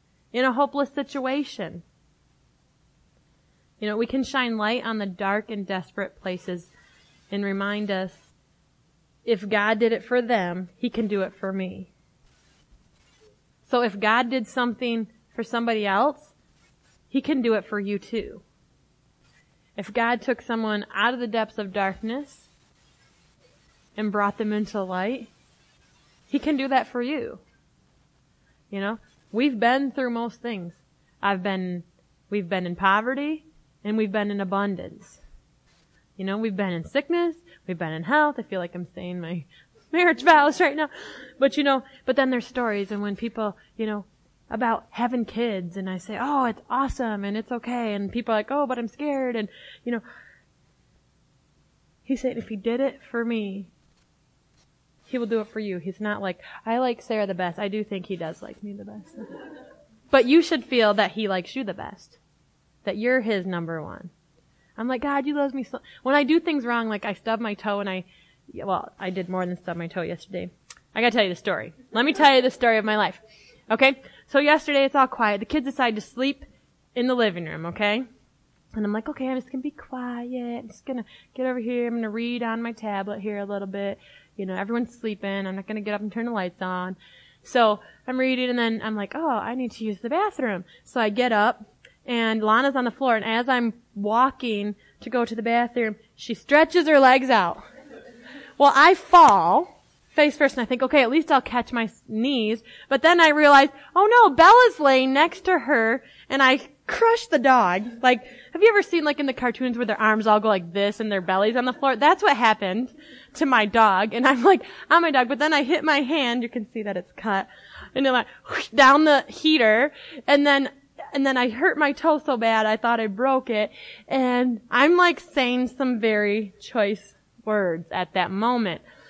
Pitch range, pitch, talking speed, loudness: 205-265 Hz, 230 Hz, 200 wpm, -22 LUFS